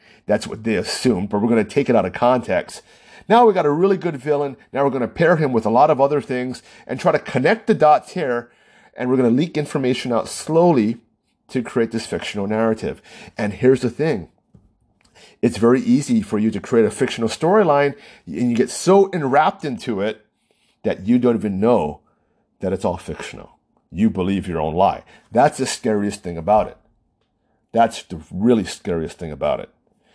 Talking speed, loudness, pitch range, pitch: 200 wpm, -19 LUFS, 110-145 Hz, 125 Hz